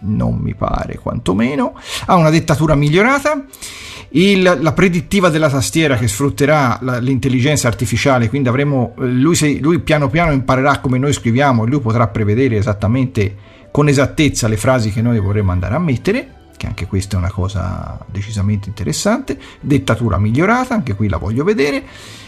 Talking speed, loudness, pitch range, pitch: 160 wpm, -15 LUFS, 105-150 Hz, 130 Hz